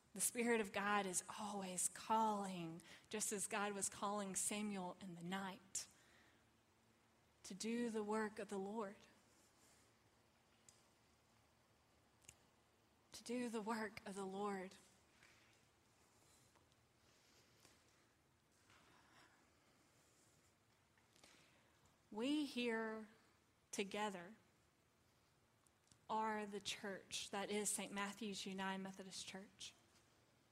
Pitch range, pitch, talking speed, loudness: 165-215 Hz, 200 Hz, 85 wpm, -45 LUFS